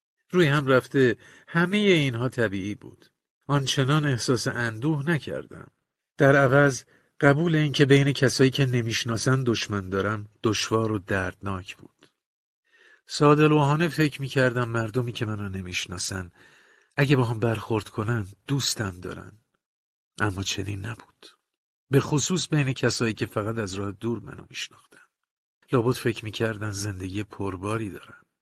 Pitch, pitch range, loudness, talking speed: 120 Hz, 105-140 Hz, -25 LUFS, 125 wpm